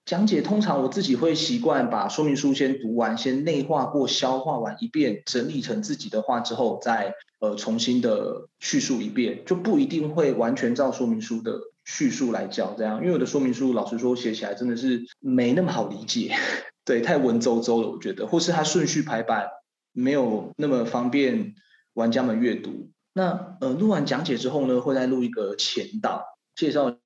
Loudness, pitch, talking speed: -25 LUFS, 145 Hz, 290 characters per minute